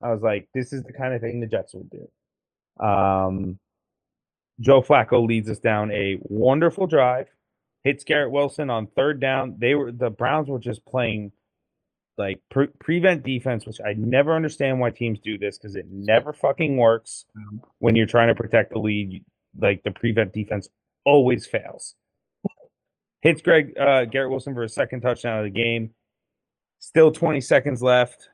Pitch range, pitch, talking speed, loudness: 110-135 Hz, 120 Hz, 170 wpm, -22 LUFS